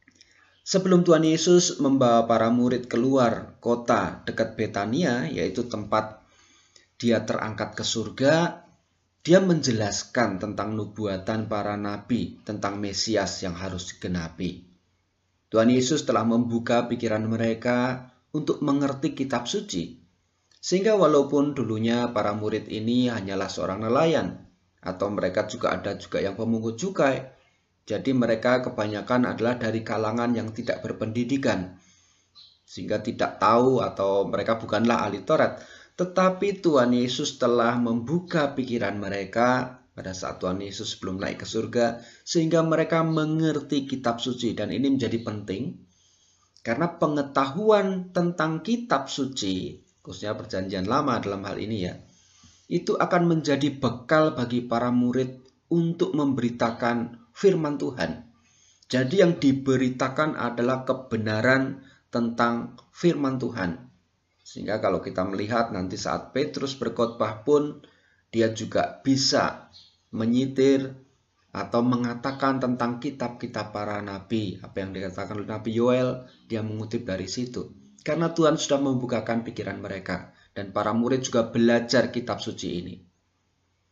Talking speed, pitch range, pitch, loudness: 120 wpm, 105-135 Hz, 120 Hz, -25 LUFS